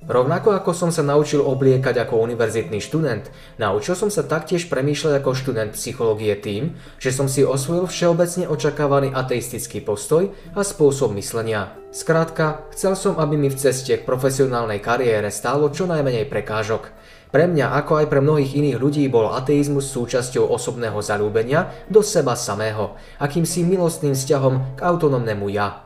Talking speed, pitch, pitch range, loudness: 150 wpm, 140 Hz, 120-160 Hz, -20 LUFS